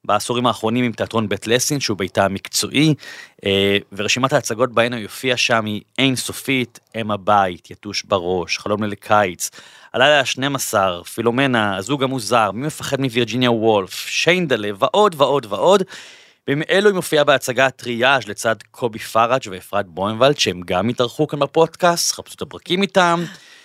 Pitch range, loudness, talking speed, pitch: 105-140 Hz, -18 LUFS, 145 wpm, 120 Hz